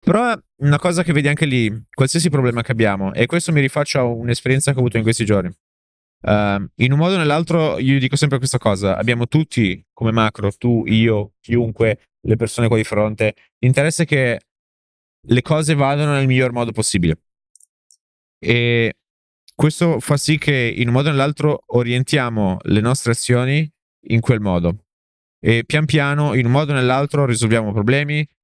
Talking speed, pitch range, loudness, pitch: 175 wpm, 110-145 Hz, -17 LUFS, 120 Hz